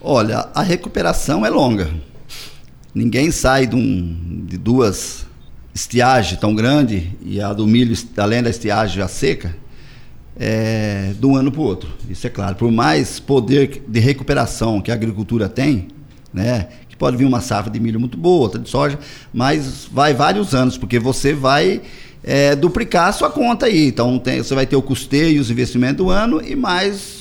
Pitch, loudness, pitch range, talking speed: 125 Hz, -17 LUFS, 110-140 Hz, 180 wpm